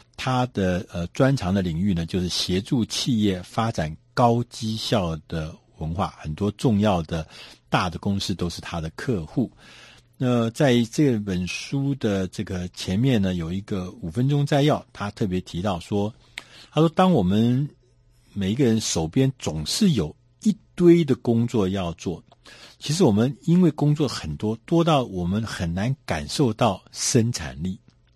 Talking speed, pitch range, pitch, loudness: 225 characters per minute, 90-125 Hz, 105 Hz, -23 LUFS